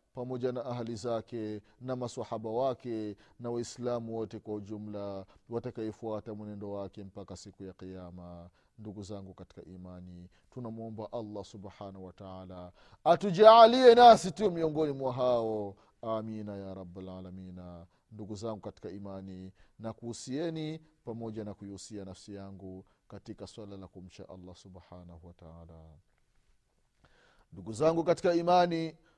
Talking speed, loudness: 115 wpm, -28 LUFS